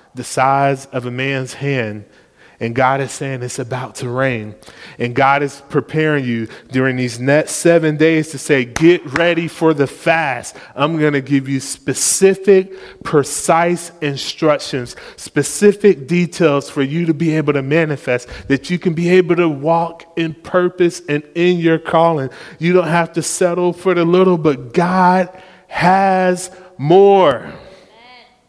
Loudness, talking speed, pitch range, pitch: -15 LUFS, 155 wpm, 135-175 Hz, 155 Hz